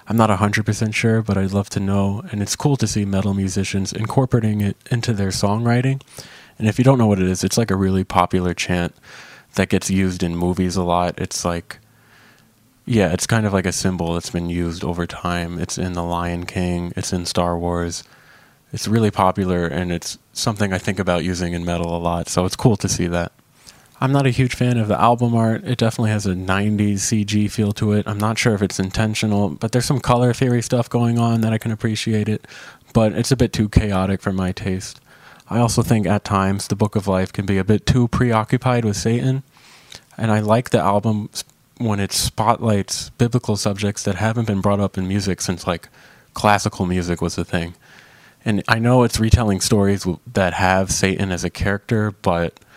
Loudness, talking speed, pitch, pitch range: -19 LUFS, 210 wpm, 105 Hz, 95-115 Hz